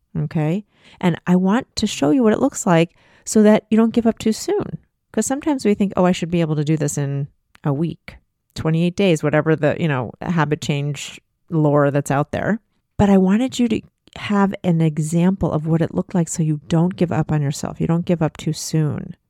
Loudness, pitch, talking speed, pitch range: -19 LUFS, 170 Hz, 225 wpm, 155-200 Hz